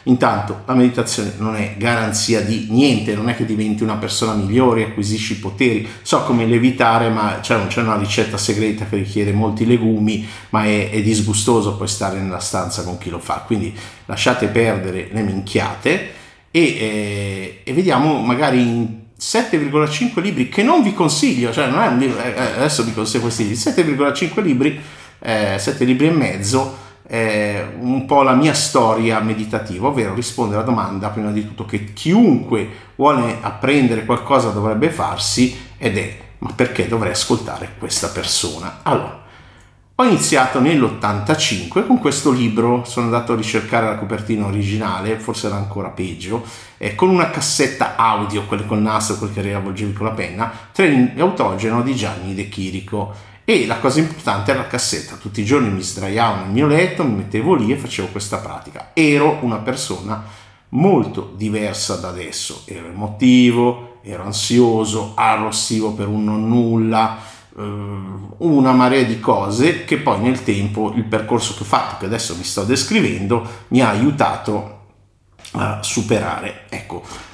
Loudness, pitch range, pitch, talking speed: -17 LUFS, 105-120 Hz, 110 Hz, 155 wpm